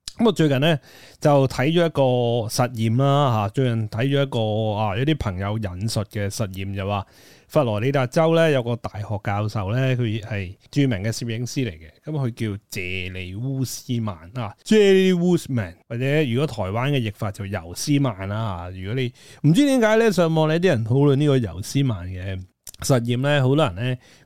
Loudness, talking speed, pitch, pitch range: -22 LUFS, 290 characters per minute, 120 Hz, 105-140 Hz